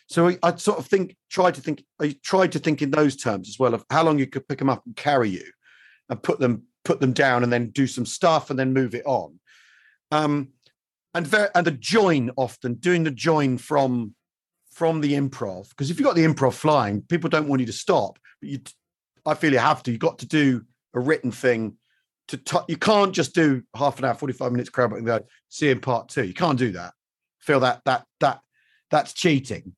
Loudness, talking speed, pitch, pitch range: -23 LUFS, 230 wpm, 140 Hz, 125-160 Hz